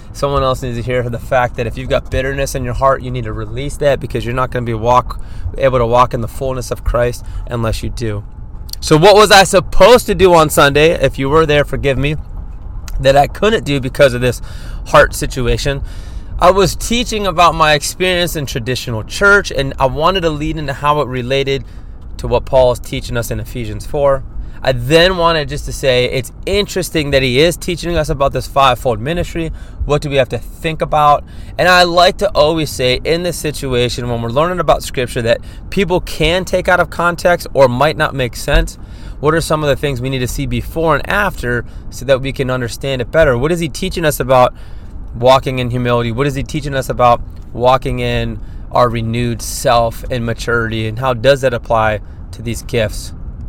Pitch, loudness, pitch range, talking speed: 130 Hz, -14 LUFS, 120-150 Hz, 210 wpm